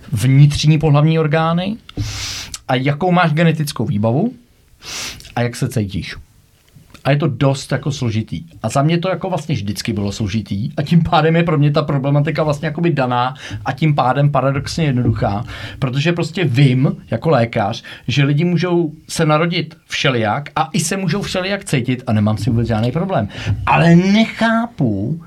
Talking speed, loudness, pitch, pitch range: 160 wpm, -17 LUFS, 145 Hz, 120-165 Hz